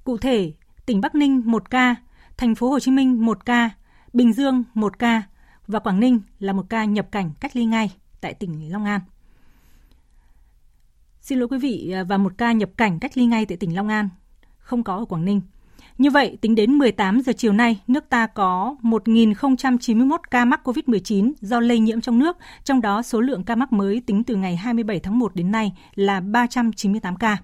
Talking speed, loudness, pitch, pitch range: 200 wpm, -20 LUFS, 225 Hz, 200-245 Hz